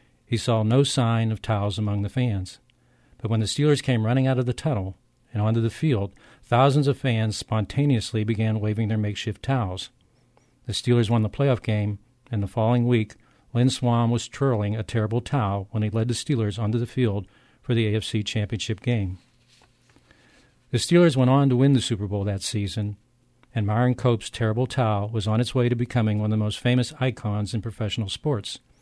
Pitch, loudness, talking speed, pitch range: 115 Hz, -24 LUFS, 195 wpm, 105-125 Hz